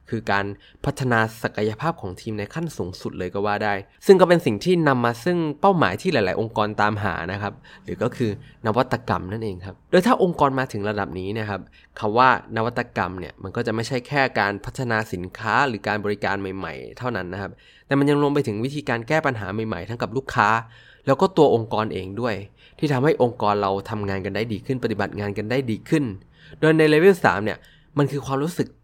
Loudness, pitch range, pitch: -22 LUFS, 100-140 Hz, 115 Hz